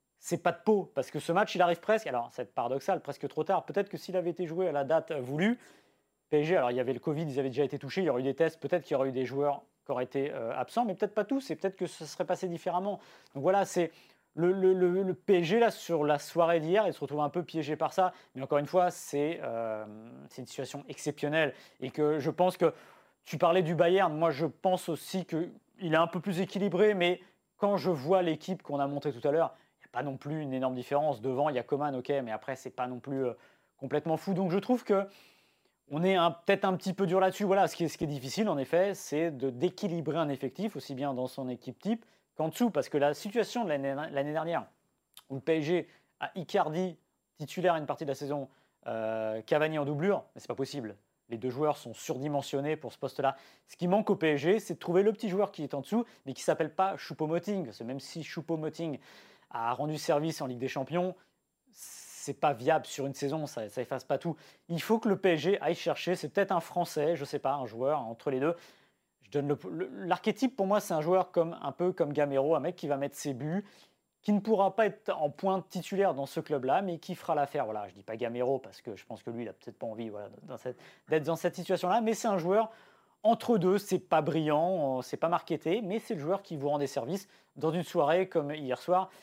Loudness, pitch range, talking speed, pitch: -31 LUFS, 140-185 Hz, 245 wpm, 160 Hz